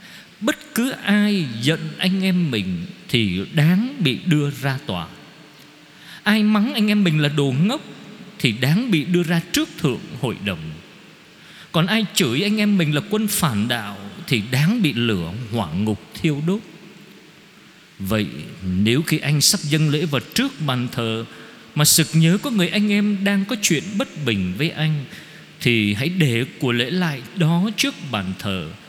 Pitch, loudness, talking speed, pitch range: 160 Hz, -20 LUFS, 170 wpm, 125-190 Hz